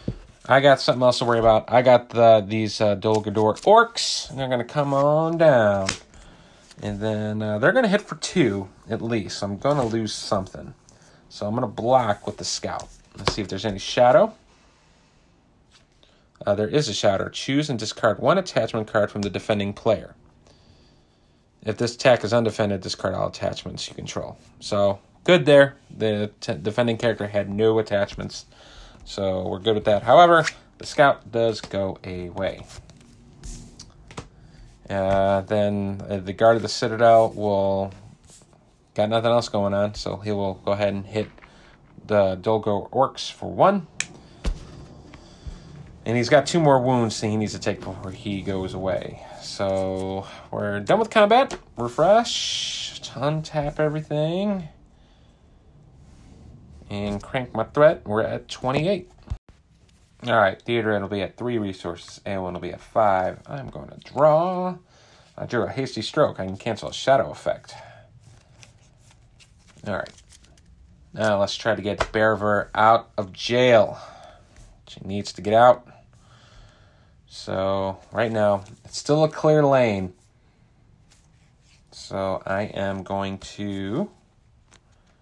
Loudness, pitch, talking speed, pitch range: -22 LUFS, 110 Hz, 145 wpm, 100-125 Hz